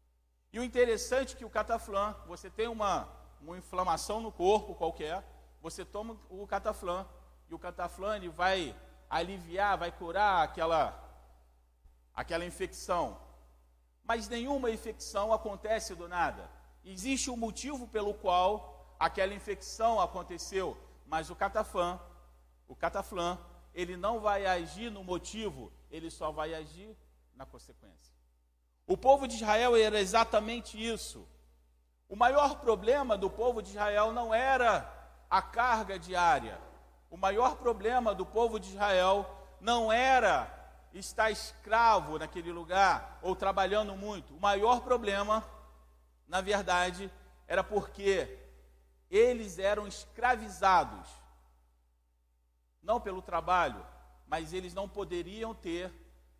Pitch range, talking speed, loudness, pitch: 165-220 Hz, 120 wpm, -32 LUFS, 195 Hz